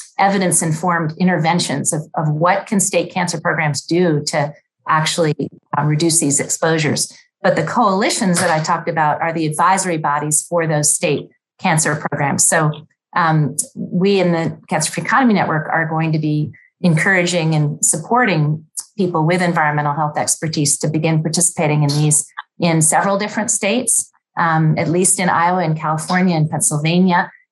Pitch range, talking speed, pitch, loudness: 155-180 Hz, 155 wpm, 165 Hz, -16 LUFS